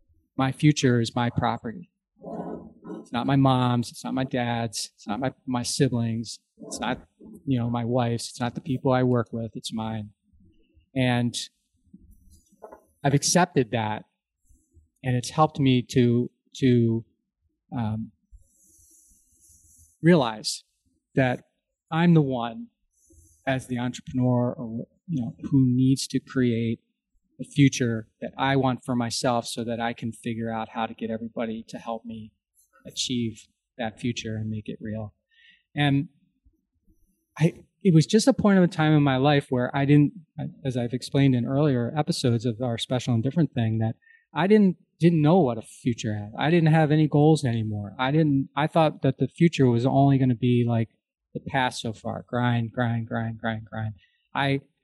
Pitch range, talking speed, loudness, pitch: 115-140 Hz, 165 wpm, -25 LUFS, 125 Hz